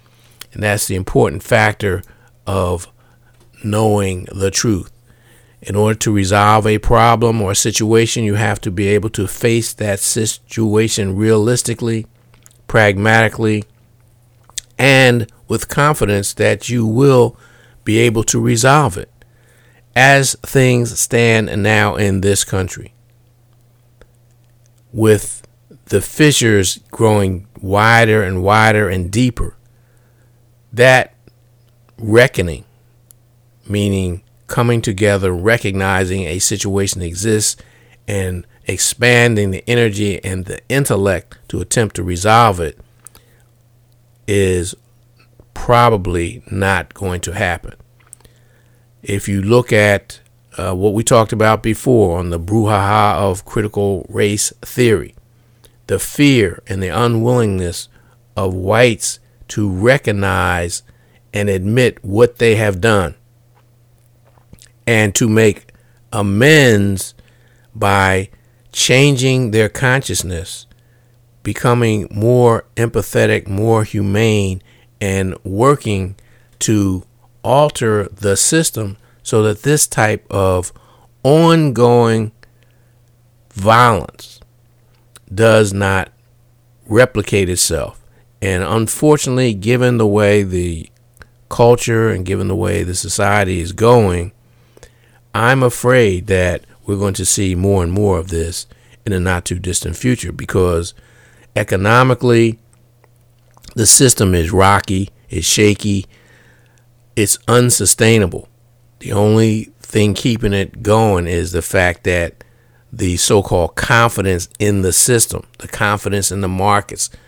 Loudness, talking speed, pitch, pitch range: -14 LUFS, 105 wpm, 115 Hz, 100-120 Hz